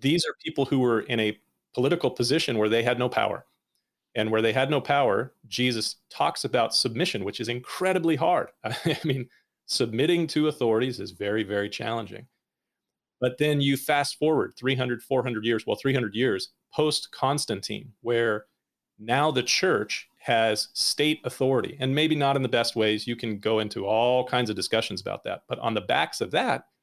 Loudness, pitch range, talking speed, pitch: -26 LUFS, 110-140 Hz, 180 wpm, 125 Hz